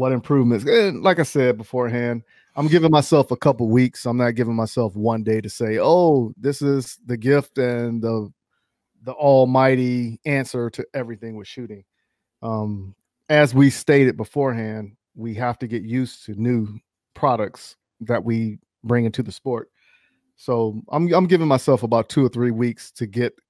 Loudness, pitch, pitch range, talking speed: -20 LUFS, 120 Hz, 115-135 Hz, 170 wpm